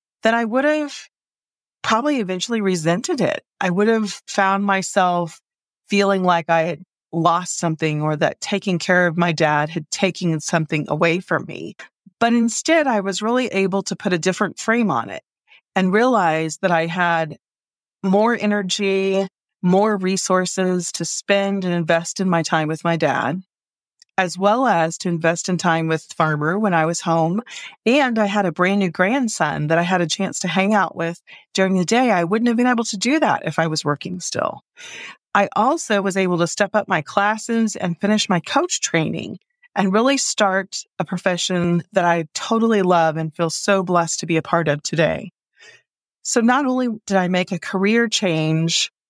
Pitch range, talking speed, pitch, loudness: 170-210 Hz, 185 wpm, 190 Hz, -19 LUFS